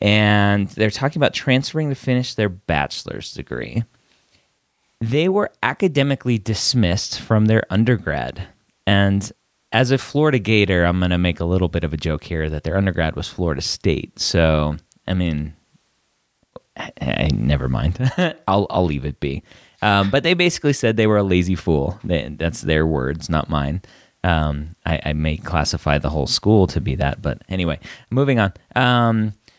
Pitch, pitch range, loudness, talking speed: 95 Hz, 80-115 Hz, -20 LUFS, 170 wpm